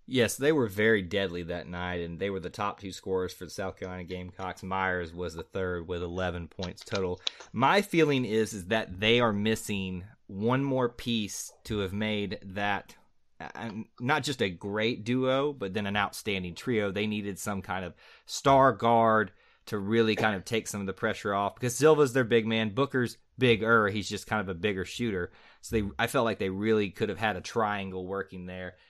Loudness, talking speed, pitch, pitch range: -29 LUFS, 200 wpm, 105 Hz, 95-115 Hz